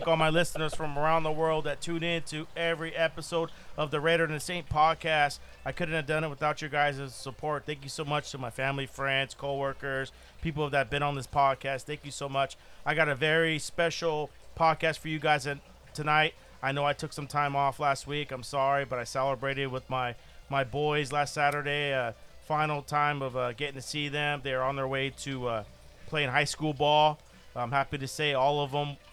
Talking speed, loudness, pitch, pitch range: 215 wpm, -30 LUFS, 145 Hz, 135-155 Hz